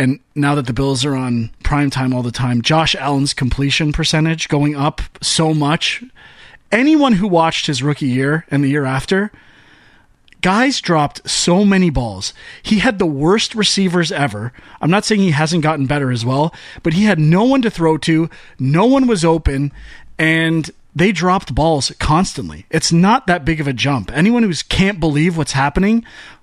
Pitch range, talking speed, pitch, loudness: 140-185 Hz, 180 wpm, 160 Hz, -15 LUFS